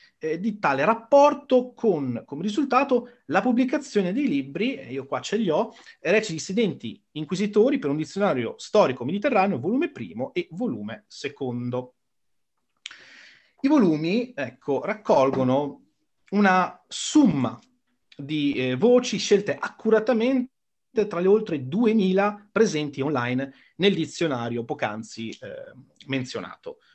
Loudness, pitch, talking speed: -24 LUFS, 205 Hz, 110 wpm